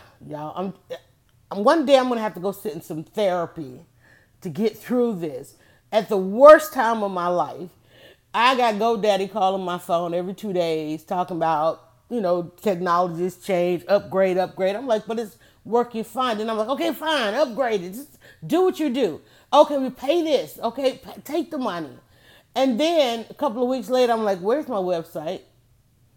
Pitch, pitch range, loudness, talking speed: 200 Hz, 175-250 Hz, -22 LUFS, 180 wpm